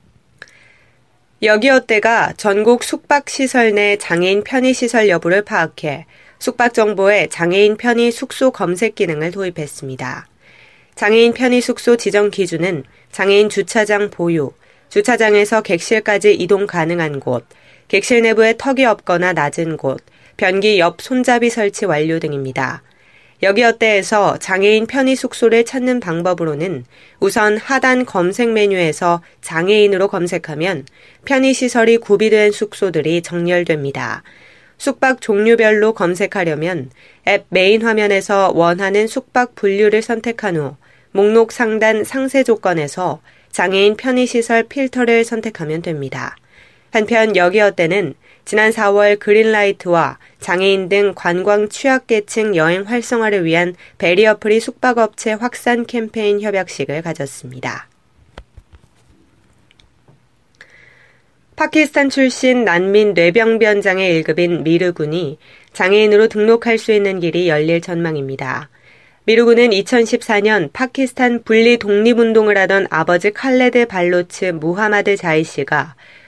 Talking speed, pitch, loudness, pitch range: 280 characters per minute, 205 Hz, -14 LUFS, 175-230 Hz